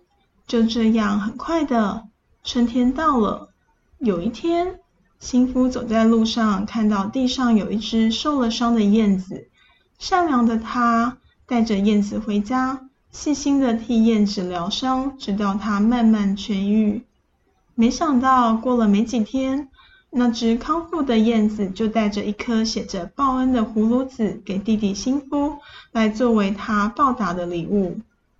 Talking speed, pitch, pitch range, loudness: 210 characters per minute, 230 Hz, 210-255 Hz, -20 LUFS